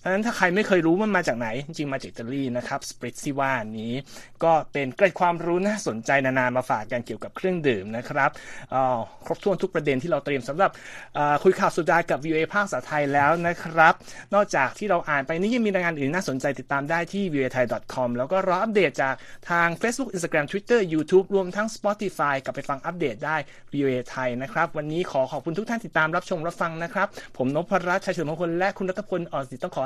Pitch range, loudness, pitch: 140-185 Hz, -25 LUFS, 165 Hz